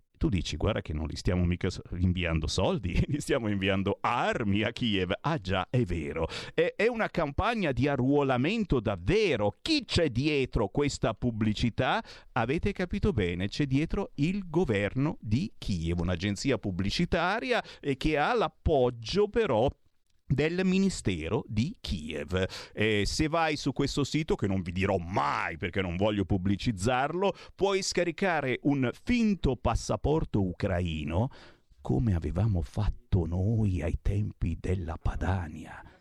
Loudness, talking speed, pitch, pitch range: -29 LUFS, 130 wpm, 110 Hz, 95-145 Hz